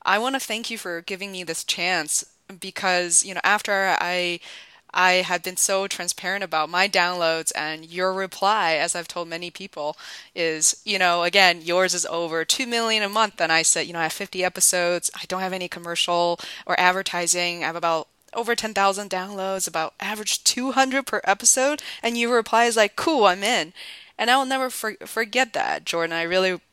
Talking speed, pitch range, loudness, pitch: 195 wpm, 170-210 Hz, -22 LUFS, 185 Hz